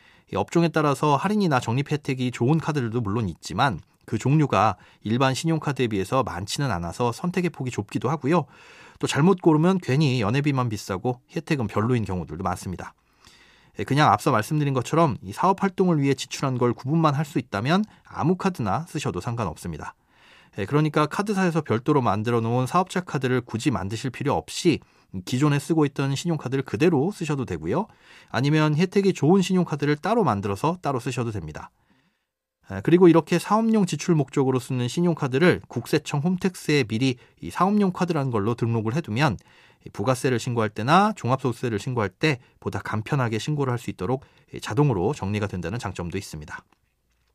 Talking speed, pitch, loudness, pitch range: 390 characters per minute, 135 Hz, -24 LUFS, 115-160 Hz